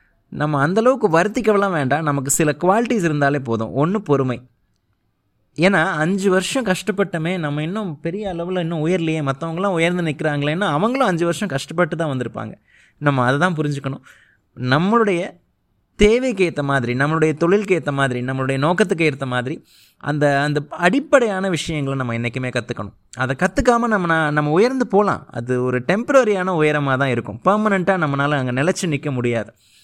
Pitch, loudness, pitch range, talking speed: 155 Hz, -19 LUFS, 135-190 Hz, 145 wpm